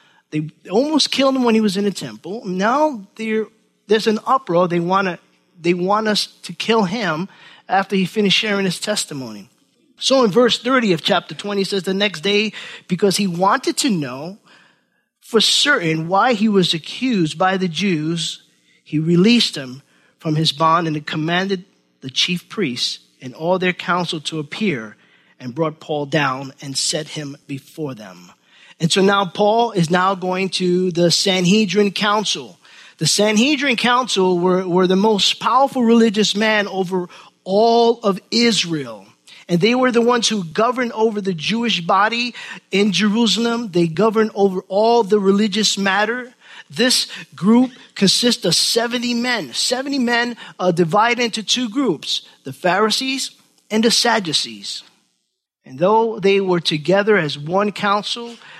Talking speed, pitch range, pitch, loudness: 155 wpm, 175-225 Hz, 200 Hz, -17 LUFS